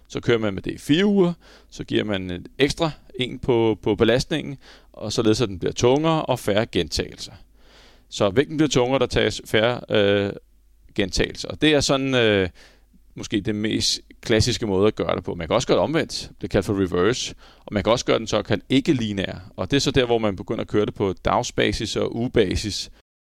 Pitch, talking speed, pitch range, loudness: 110 Hz, 215 wpm, 100-135 Hz, -22 LUFS